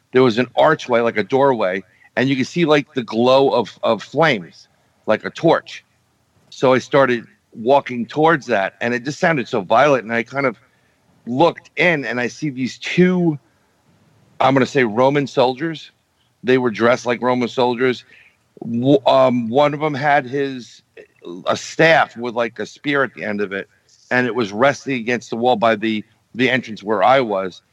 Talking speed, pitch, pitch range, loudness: 185 wpm, 125 Hz, 115-140 Hz, -18 LUFS